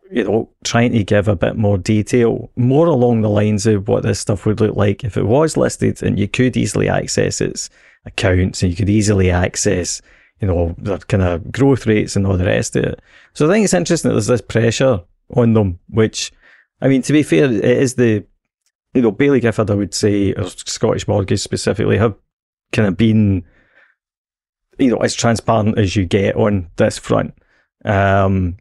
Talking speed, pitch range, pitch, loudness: 200 wpm, 100-120 Hz, 110 Hz, -16 LUFS